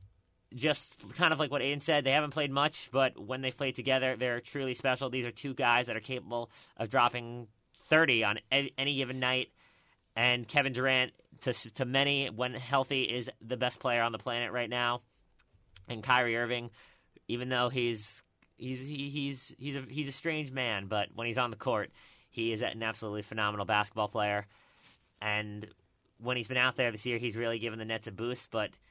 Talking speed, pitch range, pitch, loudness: 195 wpm, 110-135 Hz, 125 Hz, -32 LUFS